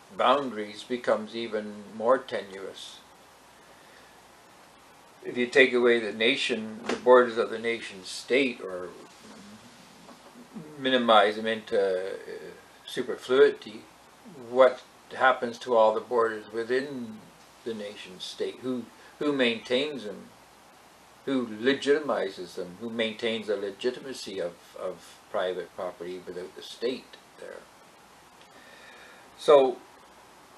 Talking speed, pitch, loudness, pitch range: 100 wpm, 120 Hz, -27 LUFS, 110-135 Hz